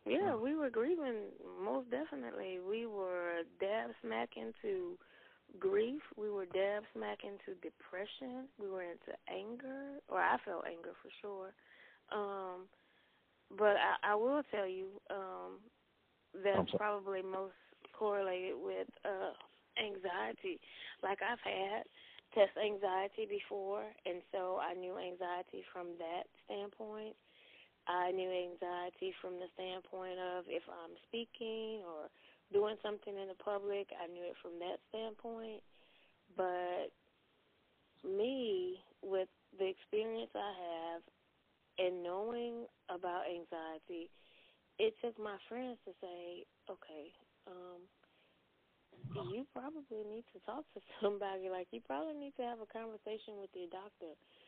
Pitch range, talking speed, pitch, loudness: 180-230 Hz, 130 wpm, 200 Hz, -42 LUFS